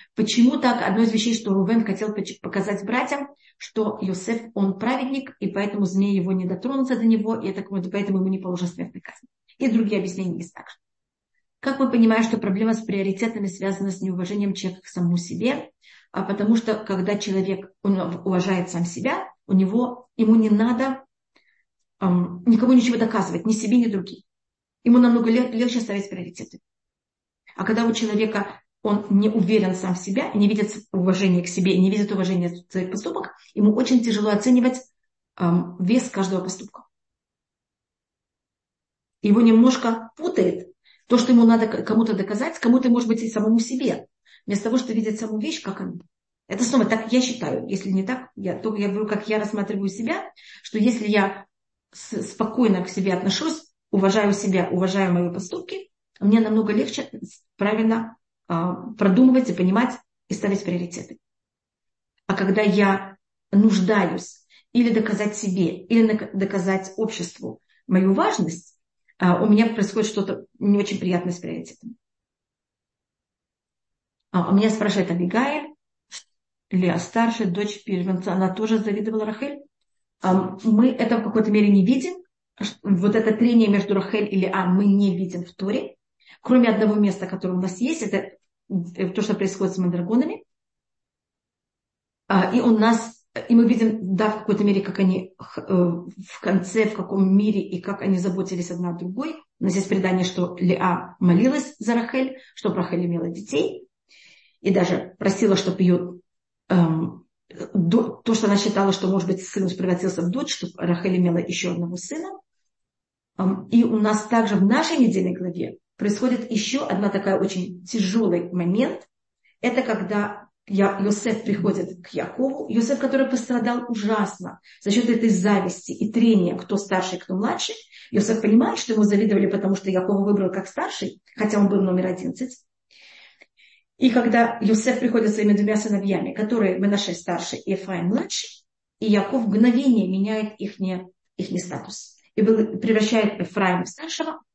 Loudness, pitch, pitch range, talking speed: -22 LUFS, 205 Hz, 190-230 Hz, 150 wpm